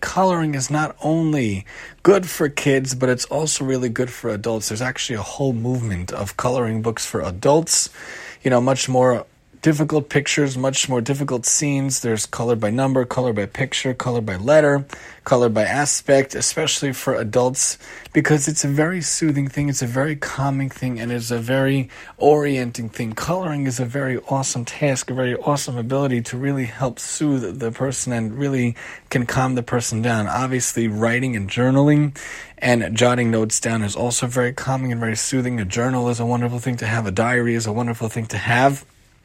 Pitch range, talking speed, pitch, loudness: 120-140 Hz, 185 wpm, 125 Hz, -20 LUFS